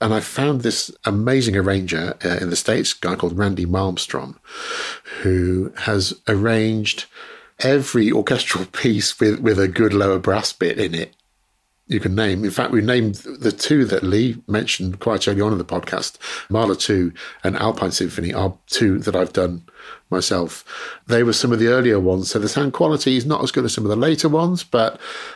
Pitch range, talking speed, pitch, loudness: 95-120 Hz, 190 wpm, 105 Hz, -19 LUFS